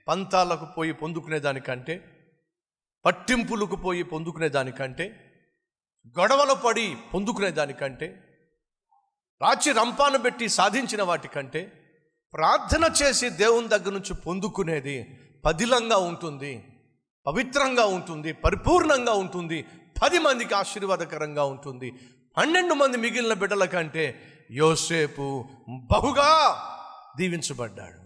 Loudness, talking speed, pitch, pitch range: -24 LUFS, 85 wpm, 170 Hz, 155-230 Hz